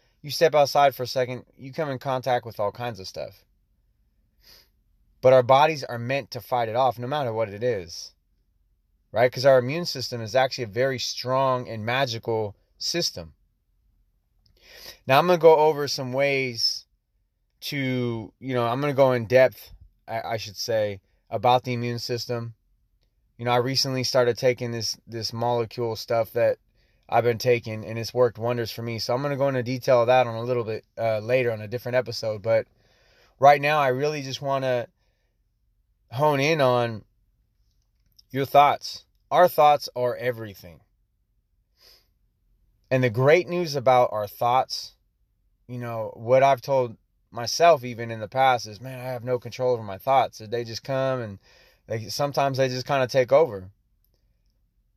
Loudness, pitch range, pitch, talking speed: -23 LUFS, 110-130 Hz, 120 Hz, 175 wpm